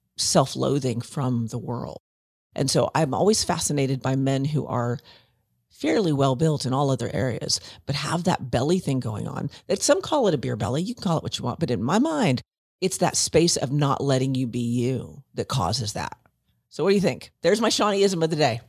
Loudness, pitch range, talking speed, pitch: -24 LUFS, 120-160 Hz, 220 wpm, 135 Hz